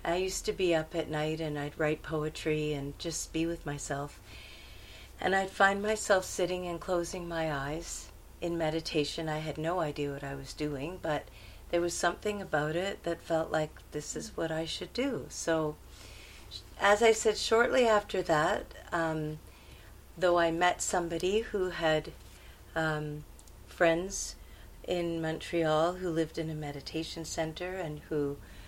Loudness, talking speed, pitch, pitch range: -32 LUFS, 160 wpm, 160 Hz, 150-180 Hz